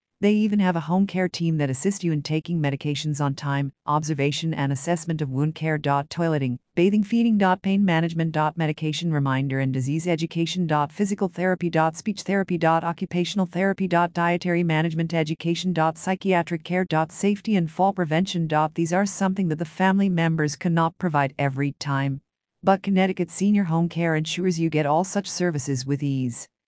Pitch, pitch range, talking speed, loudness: 165 Hz, 155-185 Hz, 180 wpm, -23 LUFS